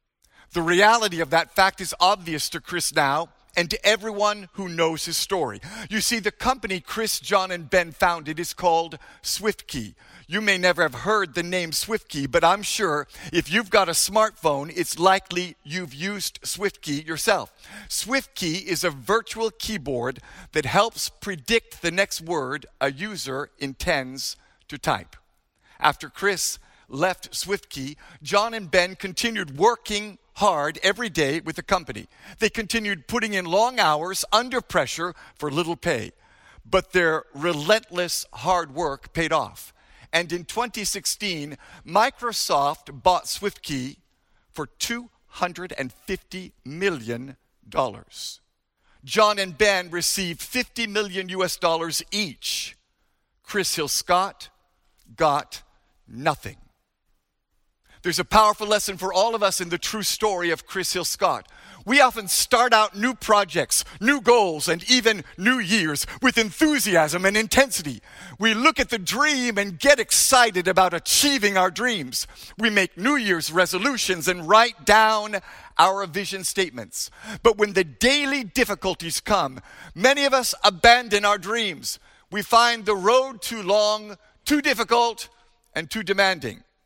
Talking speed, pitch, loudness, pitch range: 140 wpm, 190 Hz, -22 LUFS, 170-220 Hz